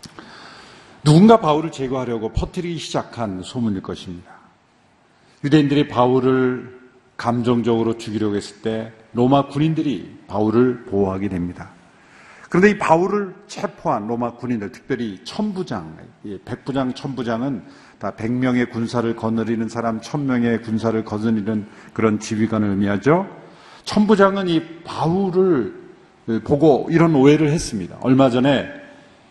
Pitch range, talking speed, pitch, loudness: 110-155 Hz, 295 characters per minute, 125 Hz, -19 LUFS